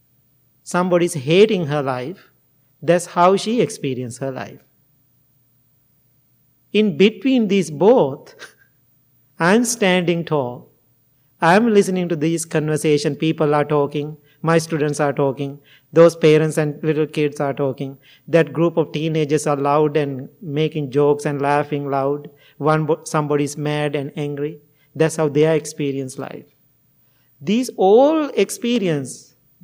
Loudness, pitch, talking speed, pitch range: -18 LUFS, 150 Hz, 125 wpm, 140-165 Hz